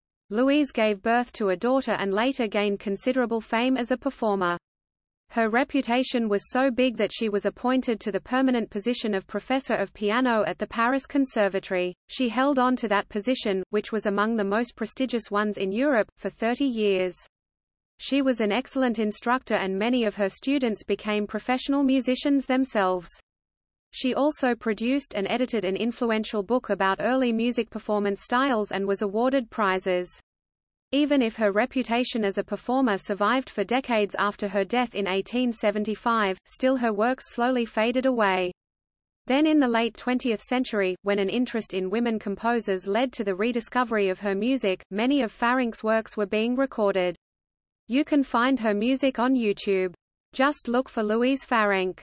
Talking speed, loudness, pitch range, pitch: 165 wpm, -25 LUFS, 205-255 Hz, 225 Hz